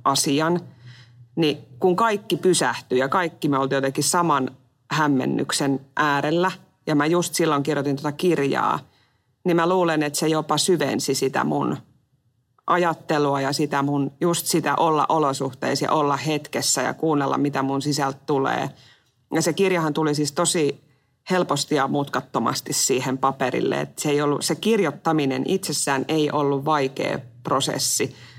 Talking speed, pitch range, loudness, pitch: 145 wpm, 135-160 Hz, -22 LUFS, 145 Hz